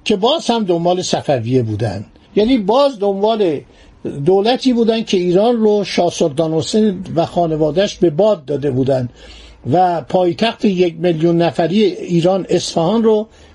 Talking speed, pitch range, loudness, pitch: 135 wpm, 165-215 Hz, -15 LUFS, 180 Hz